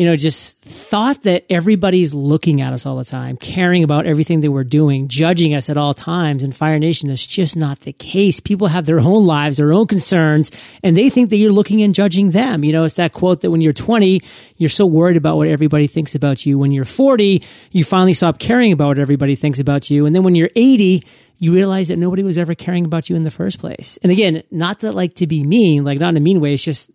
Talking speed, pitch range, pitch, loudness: 250 wpm, 150-185 Hz, 165 Hz, -14 LUFS